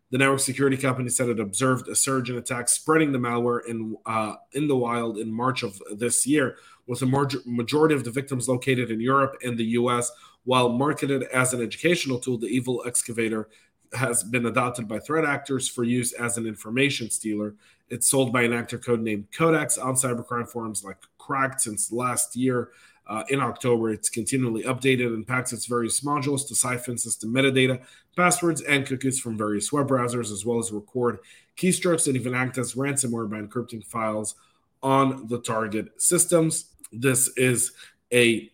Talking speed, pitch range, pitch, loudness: 180 wpm, 115-135 Hz, 125 Hz, -24 LUFS